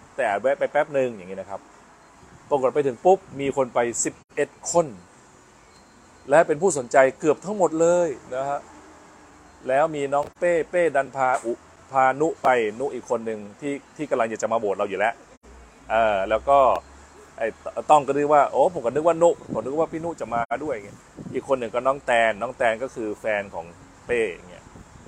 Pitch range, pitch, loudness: 130-160 Hz, 140 Hz, -23 LUFS